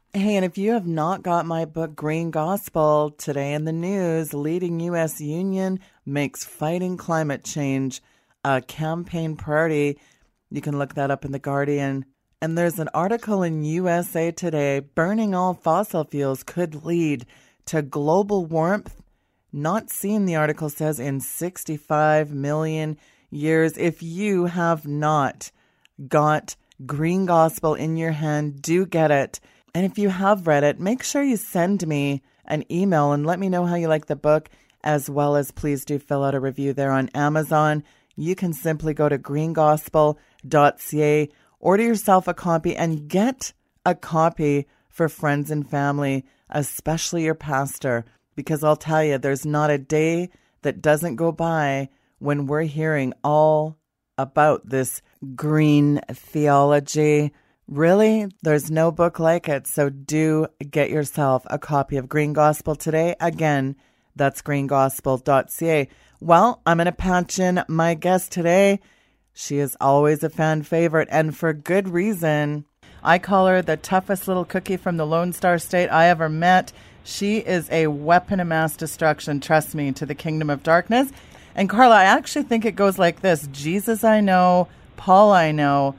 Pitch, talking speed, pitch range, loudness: 155 Hz, 160 wpm, 145-175 Hz, -21 LUFS